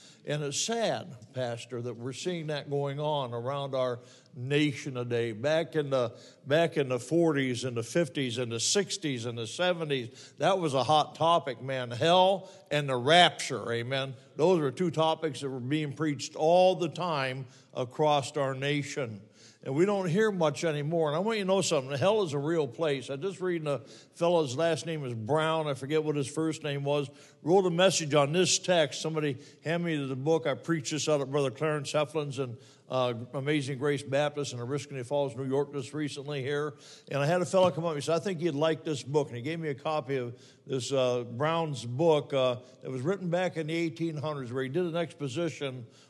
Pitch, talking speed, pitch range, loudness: 145 Hz, 210 wpm, 135-165 Hz, -30 LUFS